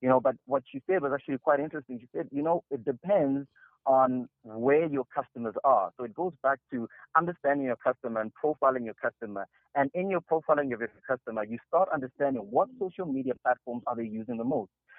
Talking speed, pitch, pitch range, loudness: 210 wpm, 135 Hz, 120-150 Hz, -30 LUFS